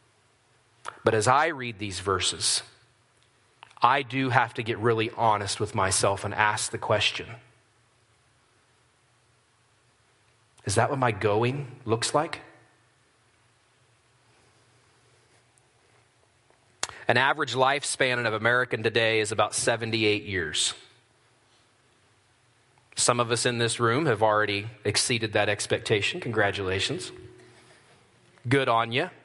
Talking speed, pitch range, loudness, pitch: 105 wpm, 110-125 Hz, -25 LUFS, 120 Hz